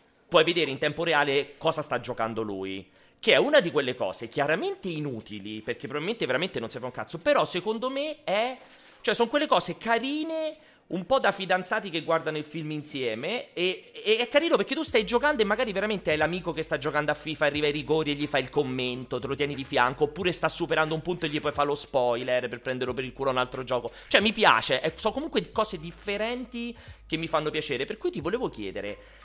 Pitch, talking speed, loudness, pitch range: 160 Hz, 225 wpm, -27 LUFS, 140-220 Hz